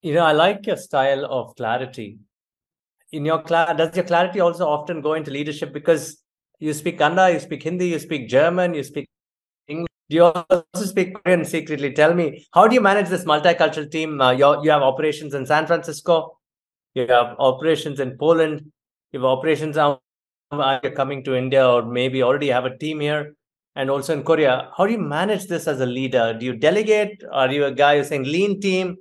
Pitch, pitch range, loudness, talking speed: 155 Hz, 140-170 Hz, -20 LUFS, 205 wpm